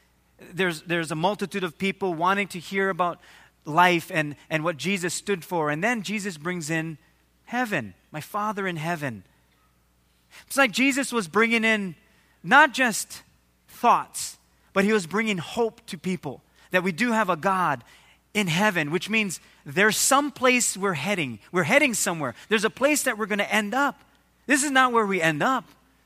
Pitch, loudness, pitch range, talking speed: 190 Hz, -24 LUFS, 160-220 Hz, 175 wpm